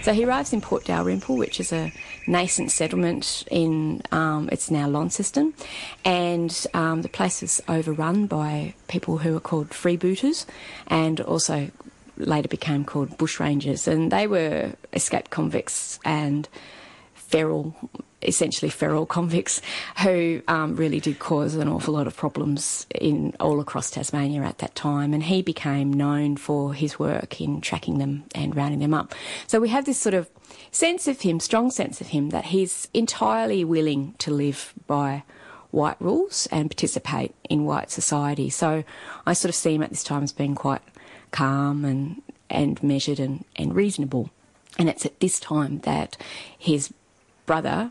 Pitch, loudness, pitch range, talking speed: 155 Hz, -24 LUFS, 145-175 Hz, 165 wpm